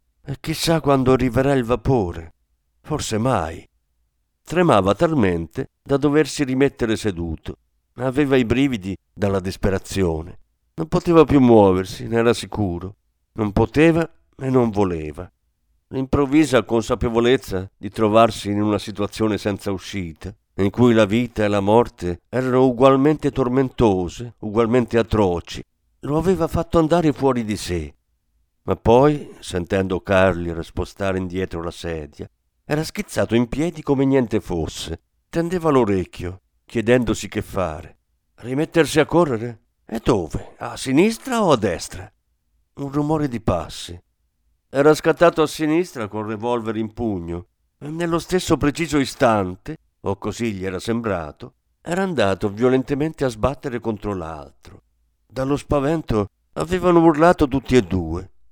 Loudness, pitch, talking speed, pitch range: -20 LUFS, 110 Hz, 130 wpm, 90-140 Hz